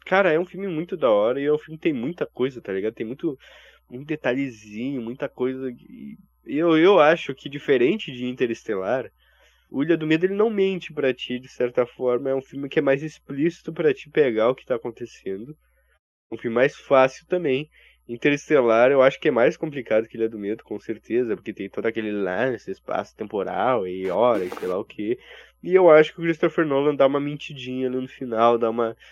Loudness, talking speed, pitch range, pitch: -23 LUFS, 210 wpm, 120-160 Hz, 135 Hz